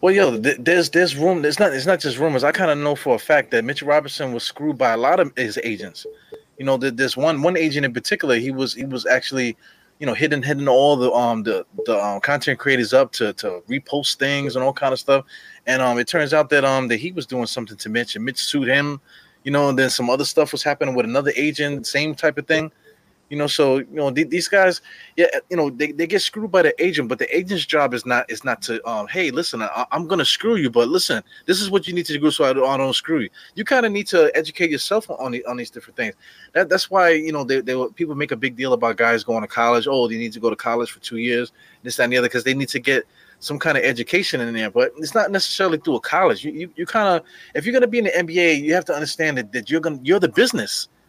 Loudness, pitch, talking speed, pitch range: -19 LUFS, 145 Hz, 275 wpm, 130-175 Hz